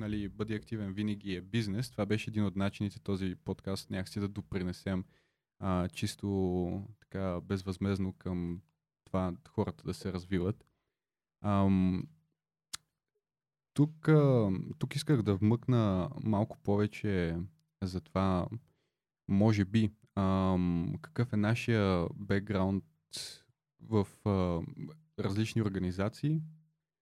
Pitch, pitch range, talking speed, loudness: 100 Hz, 95-115 Hz, 105 wpm, -33 LUFS